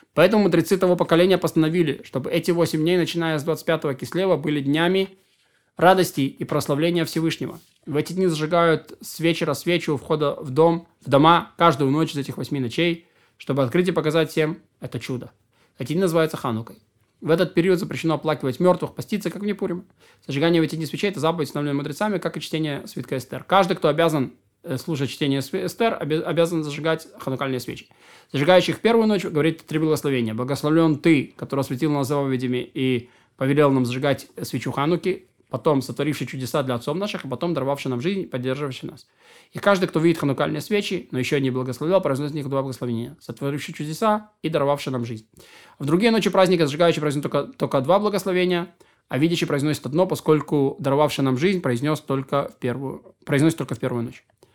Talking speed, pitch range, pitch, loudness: 175 wpm, 135-170 Hz, 155 Hz, -22 LUFS